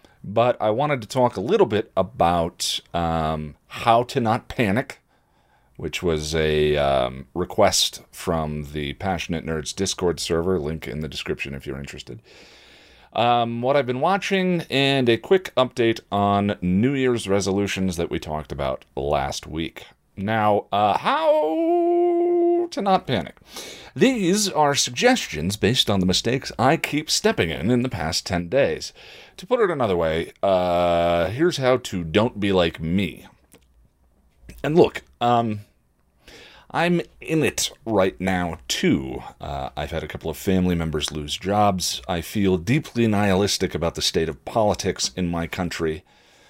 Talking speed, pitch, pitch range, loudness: 150 wpm, 95 Hz, 80-125 Hz, -22 LUFS